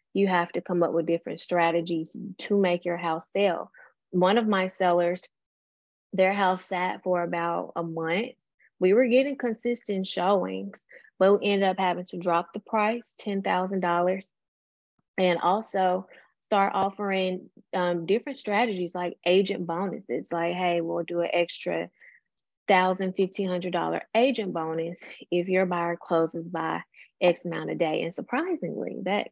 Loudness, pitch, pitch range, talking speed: -27 LUFS, 180 Hz, 170-200 Hz, 145 wpm